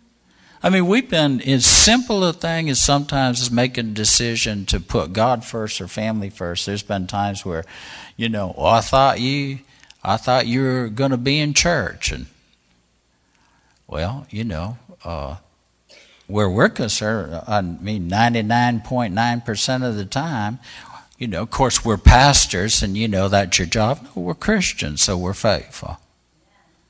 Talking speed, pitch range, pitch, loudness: 165 wpm, 95-130 Hz, 110 Hz, -18 LUFS